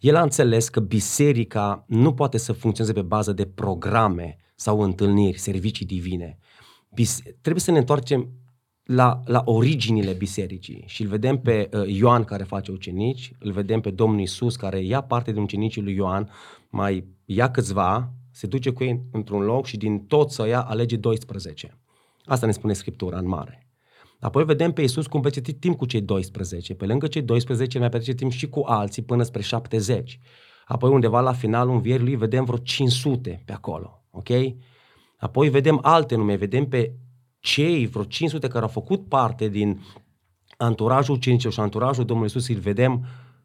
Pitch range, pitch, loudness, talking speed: 105-130 Hz, 115 Hz, -23 LUFS, 175 wpm